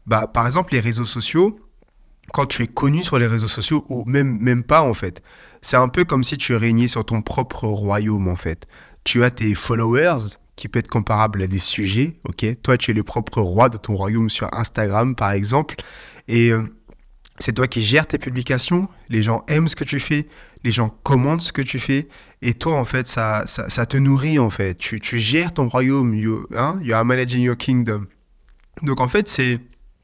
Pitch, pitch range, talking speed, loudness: 120 Hz, 110-135 Hz, 215 wpm, -19 LUFS